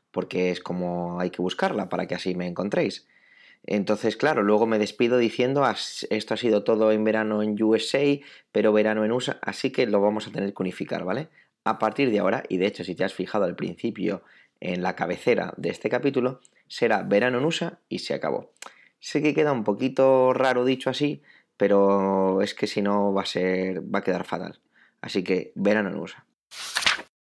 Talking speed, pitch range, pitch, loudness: 195 wpm, 95-125 Hz, 105 Hz, -25 LUFS